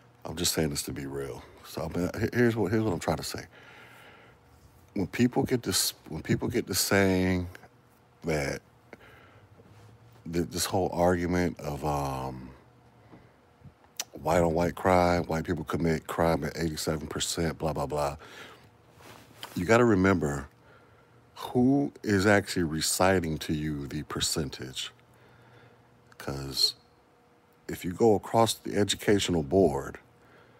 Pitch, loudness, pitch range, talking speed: 90 Hz, -28 LUFS, 80-105 Hz, 125 wpm